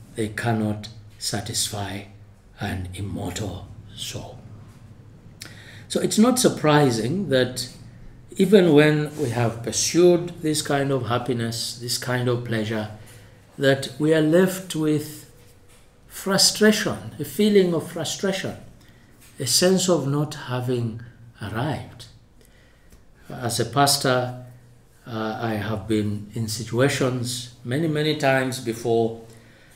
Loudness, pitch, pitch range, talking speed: -22 LUFS, 120 Hz, 110-150 Hz, 105 wpm